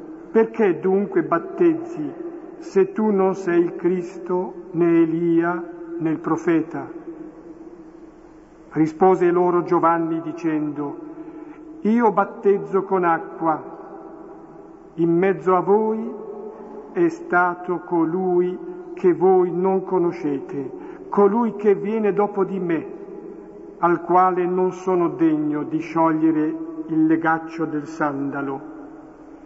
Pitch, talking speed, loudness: 190 Hz, 100 wpm, -21 LUFS